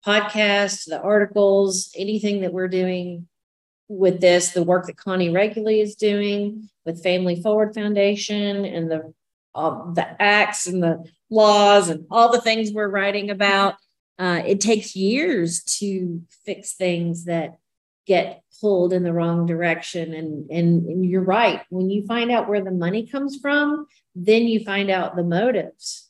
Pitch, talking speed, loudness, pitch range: 195 Hz, 160 wpm, -20 LUFS, 175-210 Hz